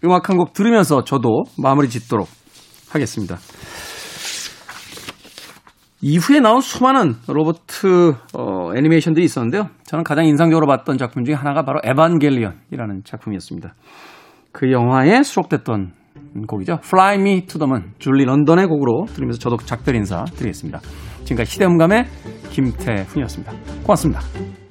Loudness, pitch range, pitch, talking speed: -17 LUFS, 115-165 Hz, 145 Hz, 365 characters per minute